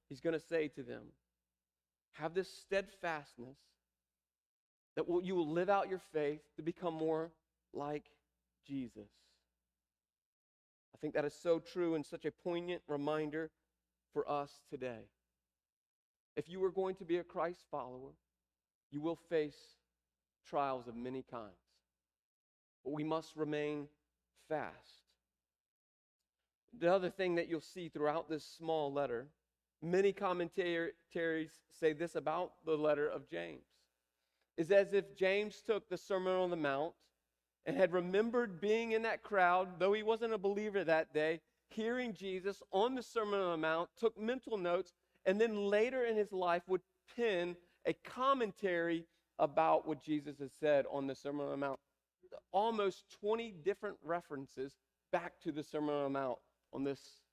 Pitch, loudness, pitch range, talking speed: 160 Hz, -38 LUFS, 125-185 Hz, 150 wpm